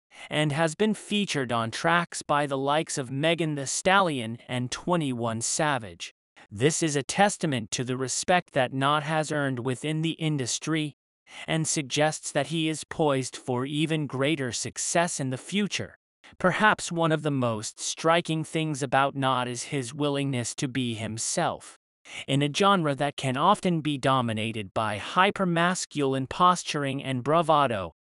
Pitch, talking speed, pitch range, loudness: 145 Hz, 155 wpm, 130-165 Hz, -26 LUFS